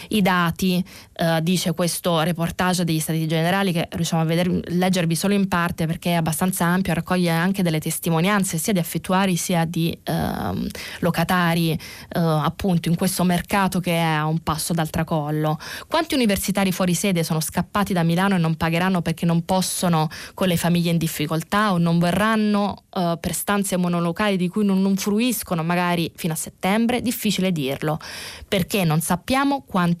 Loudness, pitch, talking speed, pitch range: -21 LUFS, 175 Hz, 170 wpm, 165-190 Hz